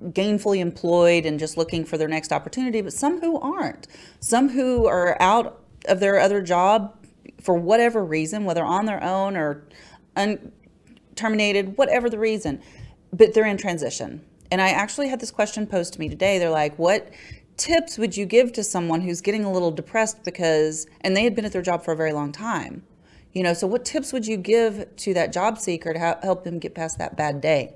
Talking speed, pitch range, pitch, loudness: 210 wpm, 170-220 Hz, 195 Hz, -22 LUFS